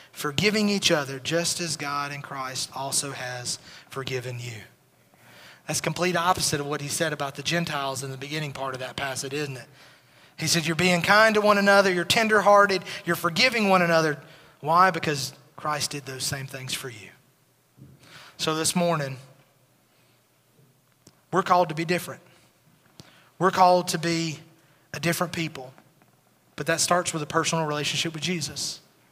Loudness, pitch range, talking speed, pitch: -24 LUFS, 140-175 Hz, 160 wpm, 155 Hz